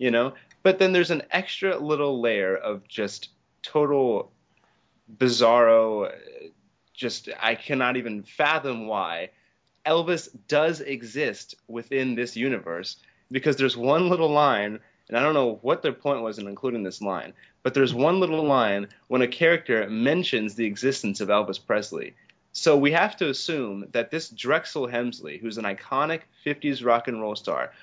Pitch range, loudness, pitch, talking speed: 115-150 Hz, -24 LUFS, 130 Hz, 155 wpm